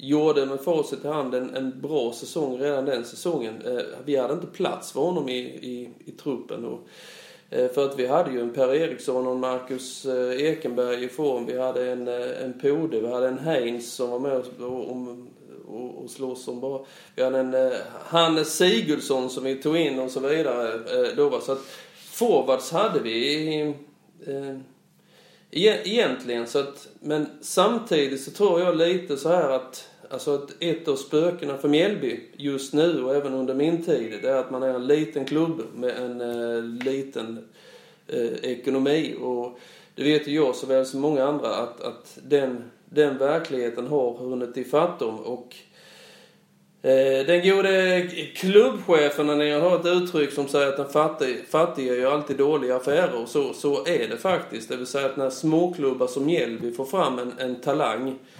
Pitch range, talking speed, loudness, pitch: 125-155 Hz, 185 wpm, -24 LUFS, 135 Hz